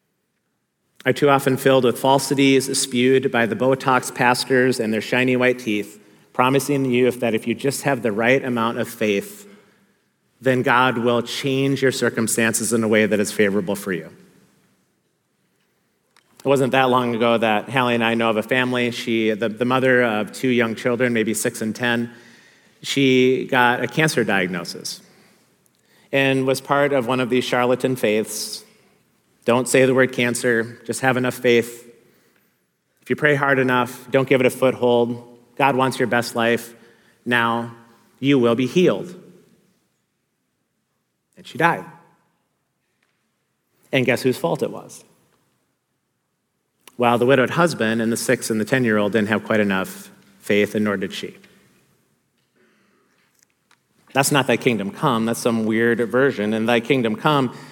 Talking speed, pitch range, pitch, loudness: 160 wpm, 115-130 Hz, 120 Hz, -19 LUFS